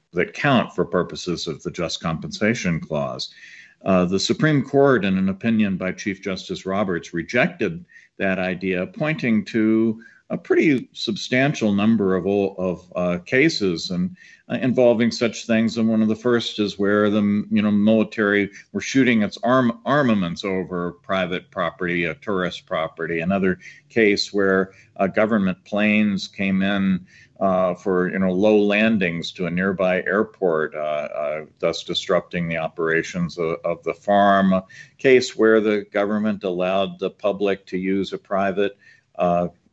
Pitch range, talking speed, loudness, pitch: 95-110 Hz, 155 wpm, -21 LUFS, 100 Hz